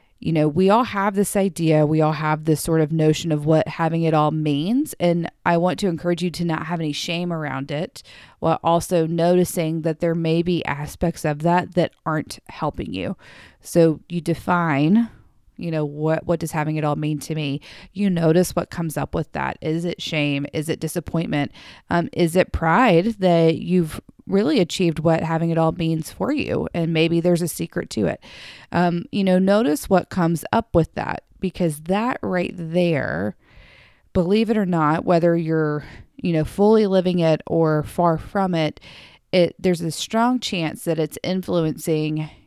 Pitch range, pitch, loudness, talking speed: 155-180 Hz, 165 Hz, -21 LUFS, 185 wpm